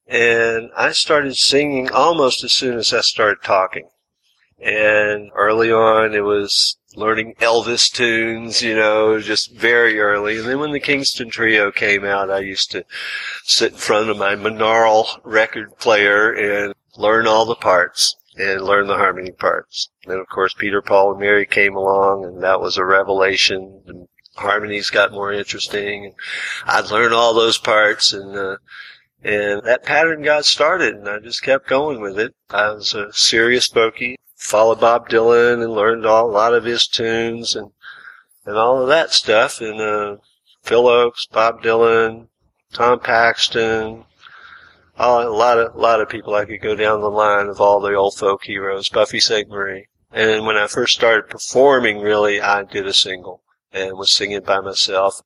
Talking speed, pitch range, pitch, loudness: 175 wpm, 100-115 Hz, 110 Hz, -16 LUFS